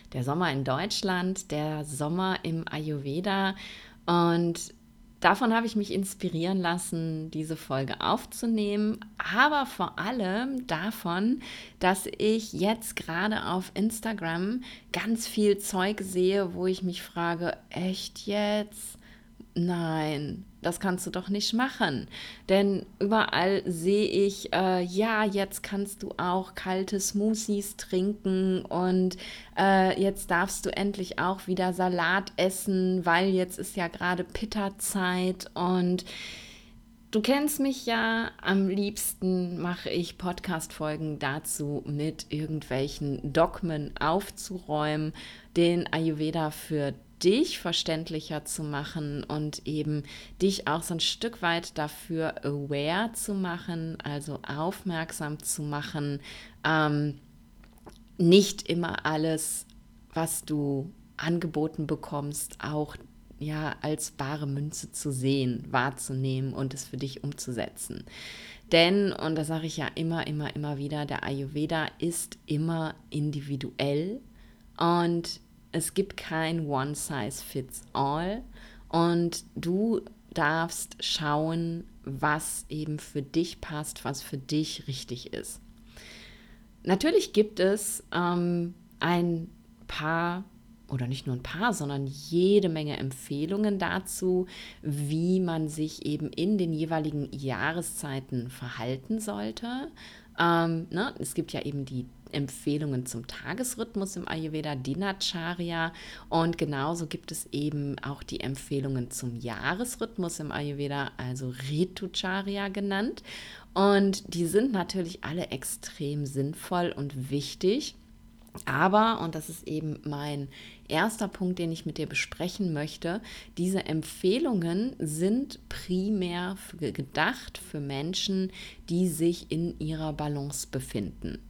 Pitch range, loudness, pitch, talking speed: 150-195 Hz, -29 LUFS, 170 Hz, 115 wpm